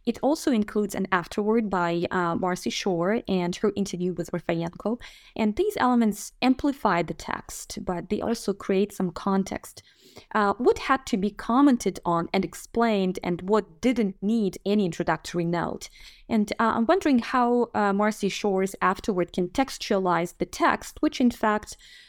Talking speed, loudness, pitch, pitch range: 155 wpm, -25 LUFS, 205 Hz, 180-230 Hz